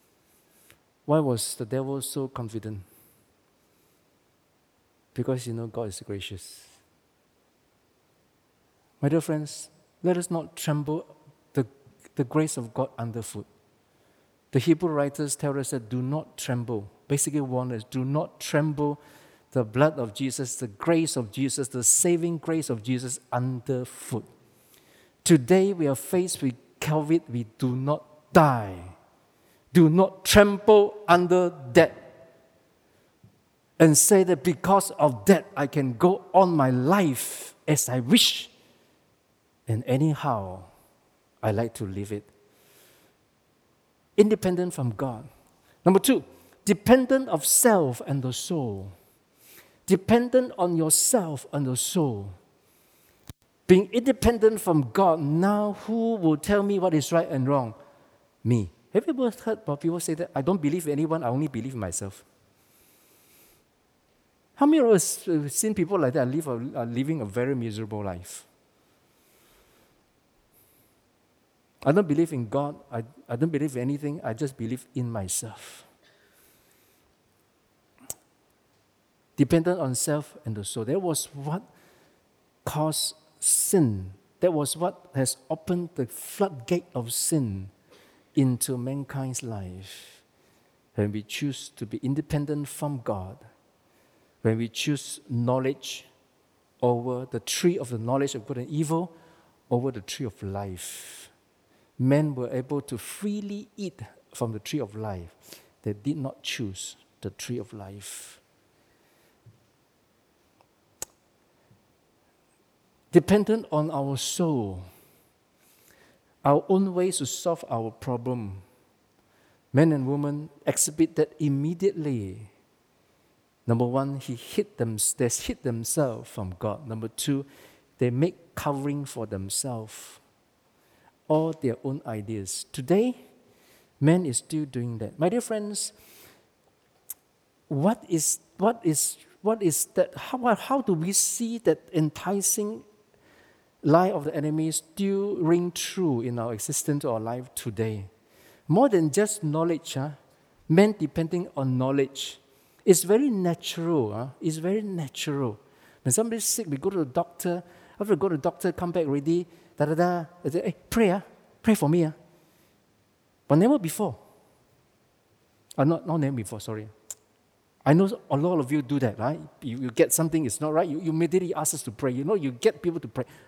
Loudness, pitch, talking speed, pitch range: -26 LUFS, 145 Hz, 140 wpm, 120-170 Hz